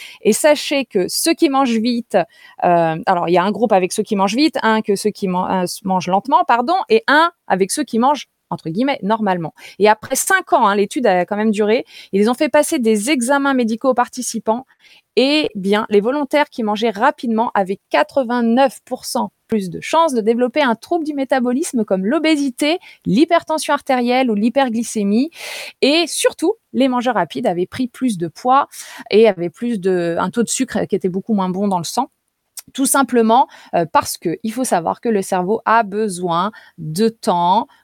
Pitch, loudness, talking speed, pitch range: 235 Hz, -17 LUFS, 185 wpm, 205-275 Hz